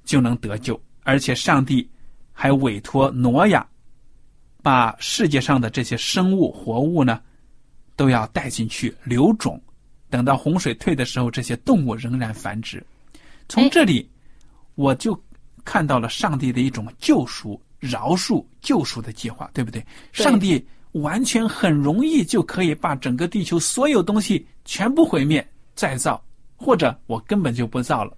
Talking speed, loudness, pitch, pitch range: 230 characters per minute, -20 LUFS, 135 Hz, 125-175 Hz